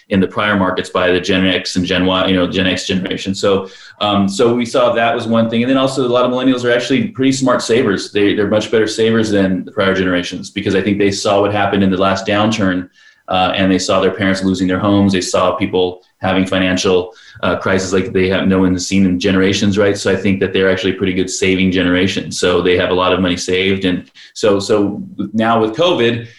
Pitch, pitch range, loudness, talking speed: 95 Hz, 95-105 Hz, -14 LUFS, 240 wpm